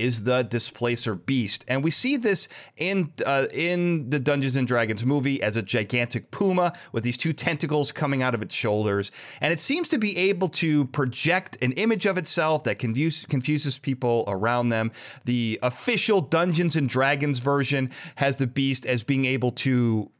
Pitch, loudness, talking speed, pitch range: 135 Hz, -24 LUFS, 175 wpm, 120-165 Hz